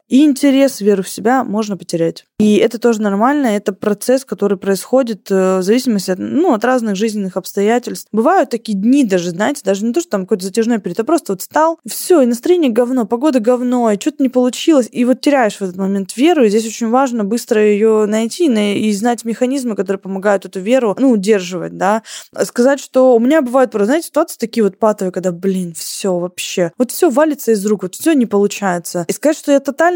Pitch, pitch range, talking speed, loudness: 225 Hz, 200-260 Hz, 205 wpm, -15 LUFS